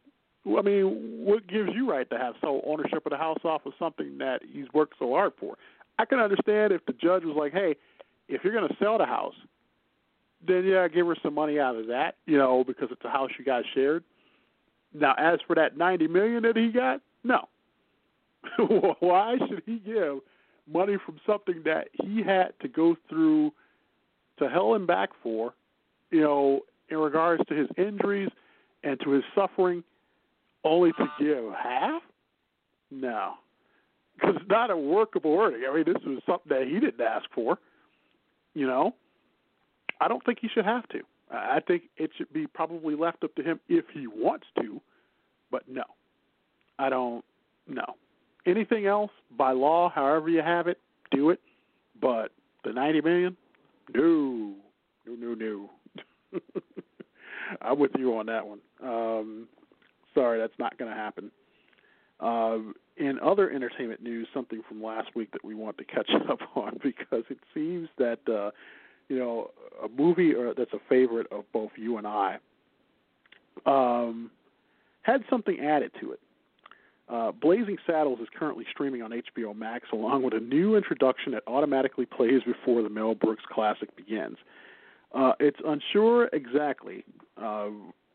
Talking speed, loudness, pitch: 165 wpm, -28 LUFS, 160 Hz